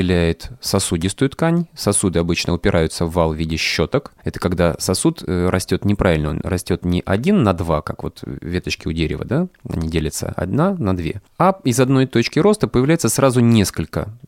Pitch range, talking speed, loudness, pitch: 85-125 Hz, 170 wpm, -18 LUFS, 95 Hz